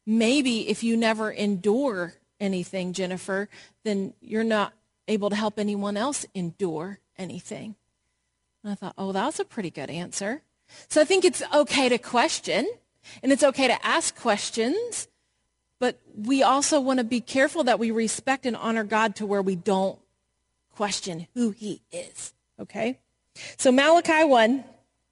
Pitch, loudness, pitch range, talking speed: 215 Hz, -25 LUFS, 195-260 Hz, 155 wpm